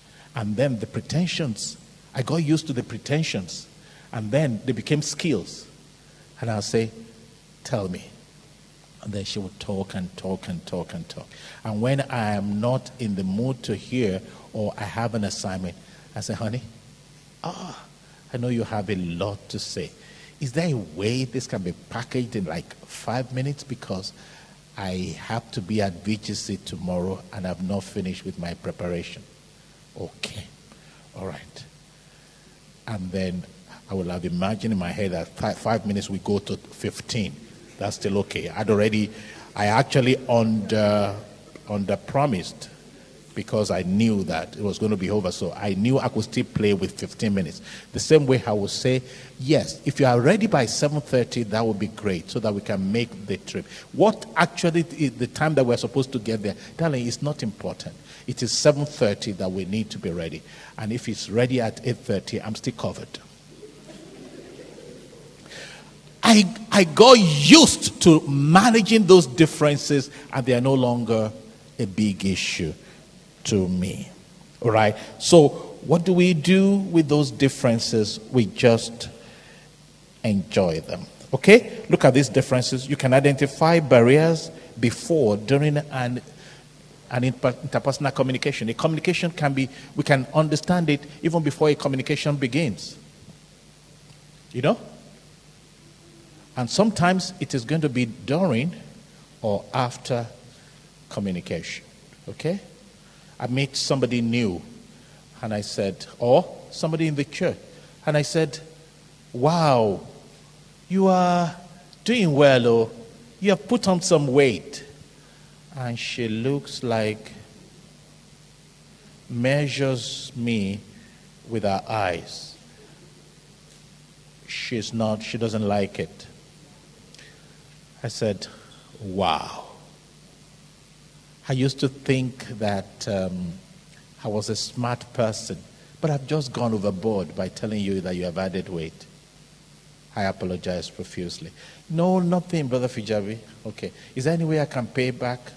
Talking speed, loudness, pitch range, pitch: 145 wpm, -23 LUFS, 110-155 Hz, 125 Hz